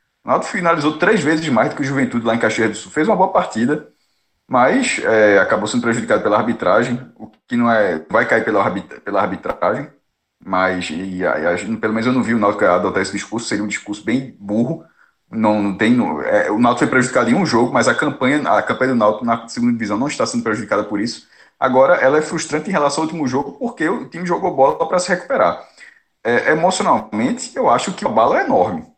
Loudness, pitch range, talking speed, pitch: -17 LUFS, 105-155 Hz, 225 wpm, 120 Hz